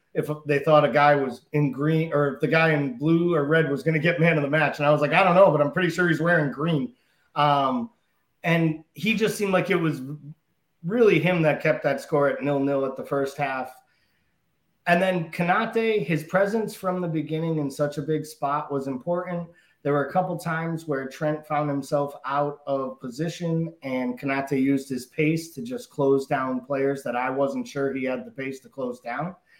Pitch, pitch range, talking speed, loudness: 150 Hz, 140-170 Hz, 215 wpm, -24 LUFS